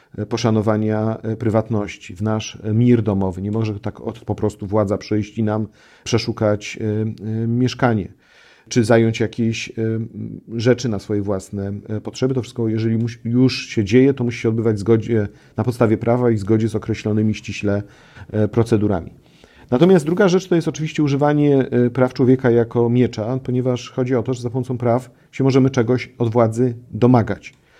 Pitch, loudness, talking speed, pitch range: 115 Hz, -19 LUFS, 150 wpm, 110-125 Hz